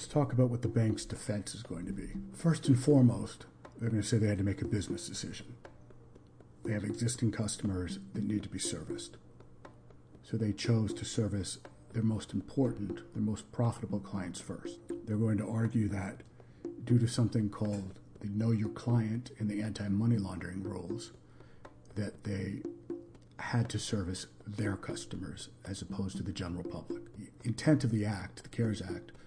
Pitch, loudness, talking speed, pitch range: 105 Hz, -35 LUFS, 175 wpm, 100-115 Hz